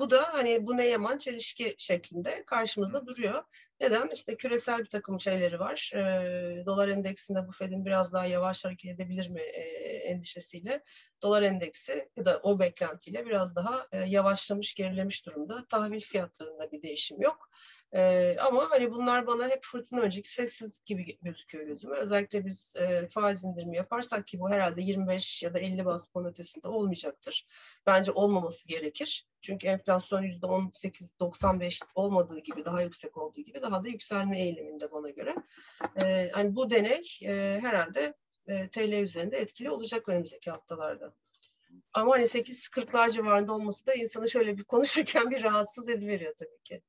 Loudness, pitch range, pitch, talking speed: -31 LUFS, 180-235 Hz, 195 Hz, 155 wpm